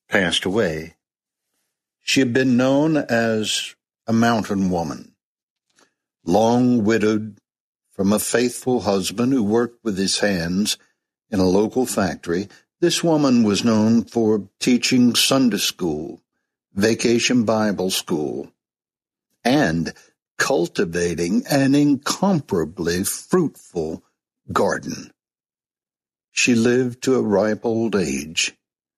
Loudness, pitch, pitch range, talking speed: -20 LUFS, 115 Hz, 105-125 Hz, 100 wpm